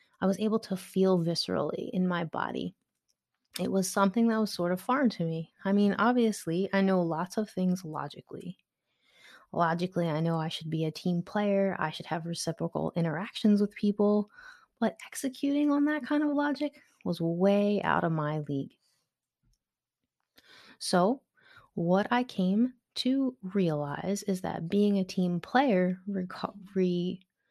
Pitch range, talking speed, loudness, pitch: 175-220 Hz, 155 wpm, -30 LUFS, 195 Hz